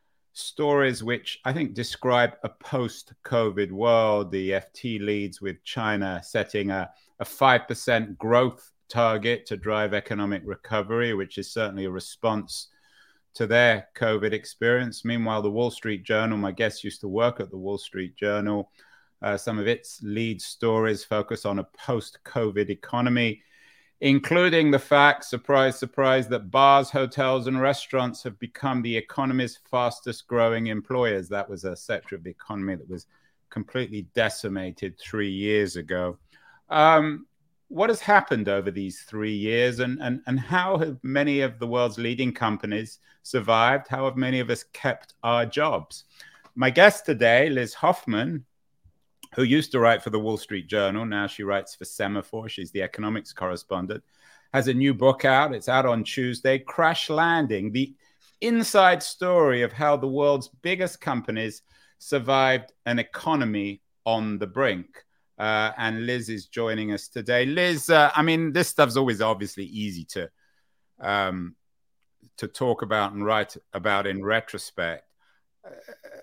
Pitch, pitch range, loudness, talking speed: 115 Hz, 105-130 Hz, -24 LUFS, 155 wpm